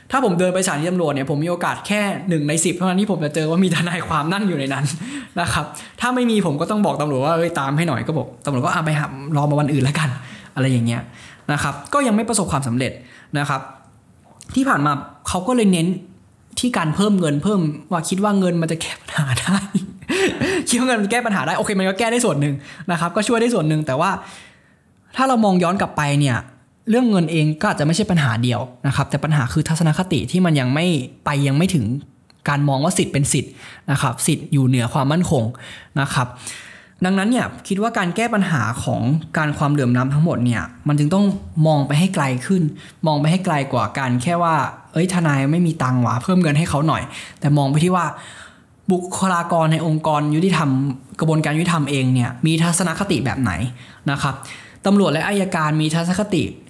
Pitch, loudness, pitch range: 160 Hz, -19 LUFS, 140-185 Hz